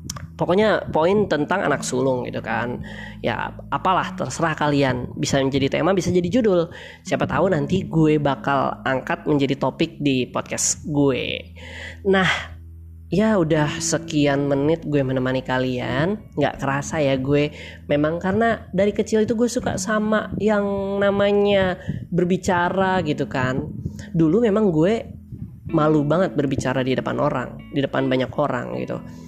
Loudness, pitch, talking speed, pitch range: -21 LUFS, 150 Hz, 135 wpm, 135-190 Hz